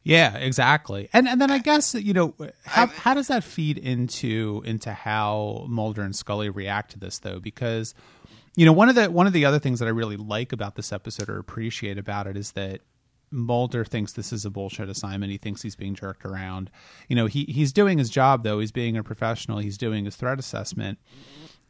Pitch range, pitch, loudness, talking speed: 105-140 Hz, 115 Hz, -24 LUFS, 215 wpm